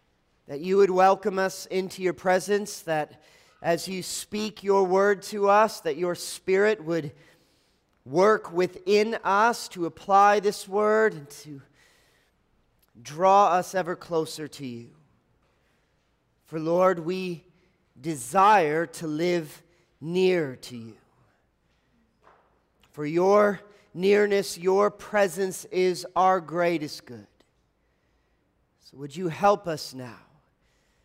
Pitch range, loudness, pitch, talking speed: 155-195 Hz, -24 LUFS, 180 Hz, 115 wpm